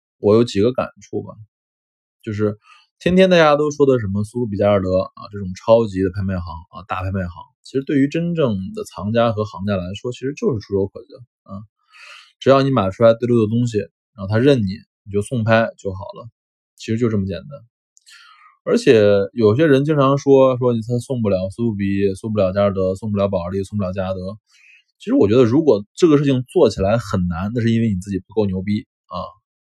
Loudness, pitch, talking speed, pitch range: -18 LUFS, 105 Hz, 310 characters per minute, 95-125 Hz